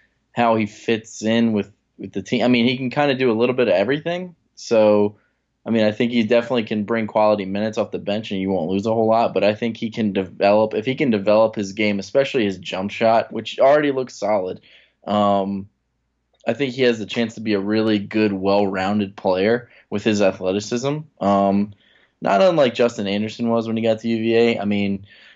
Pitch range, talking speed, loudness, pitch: 100-115 Hz, 220 wpm, -20 LUFS, 110 Hz